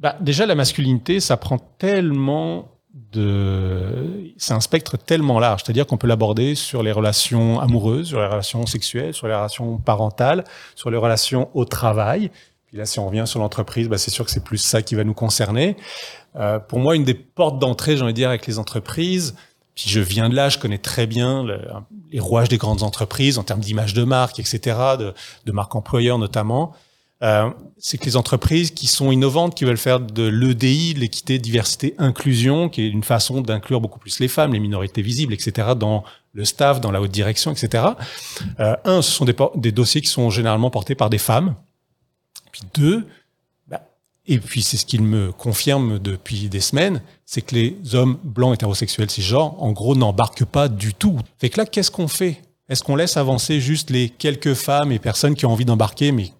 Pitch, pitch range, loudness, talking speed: 120 Hz, 110-140 Hz, -19 LUFS, 205 wpm